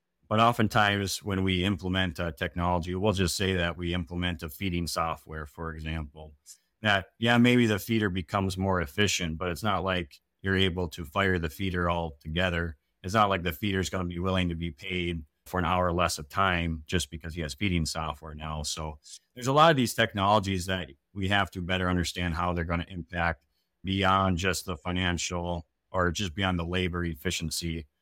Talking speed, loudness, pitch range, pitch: 200 wpm, -28 LUFS, 85-95 Hz, 90 Hz